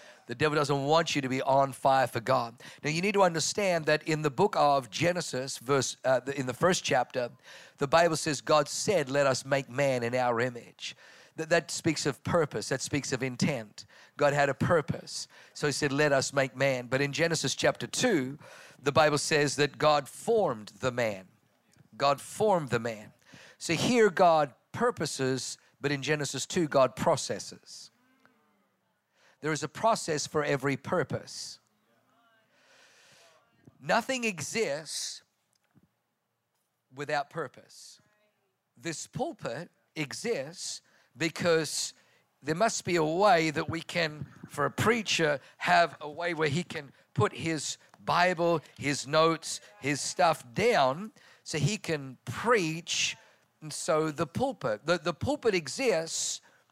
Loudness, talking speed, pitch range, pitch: -29 LUFS, 145 wpm, 135-170 Hz, 150 Hz